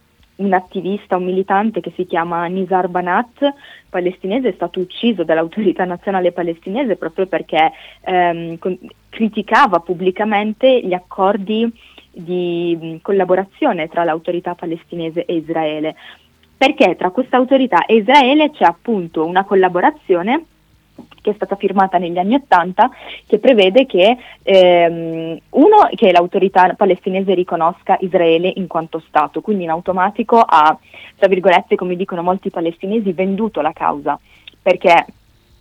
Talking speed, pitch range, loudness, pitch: 130 wpm, 175-215 Hz, -15 LUFS, 185 Hz